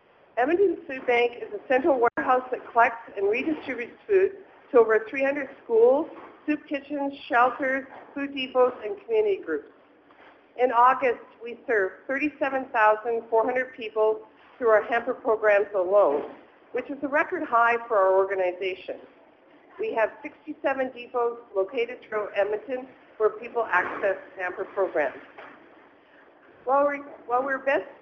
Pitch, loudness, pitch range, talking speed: 255 Hz, -25 LUFS, 220-290 Hz, 125 wpm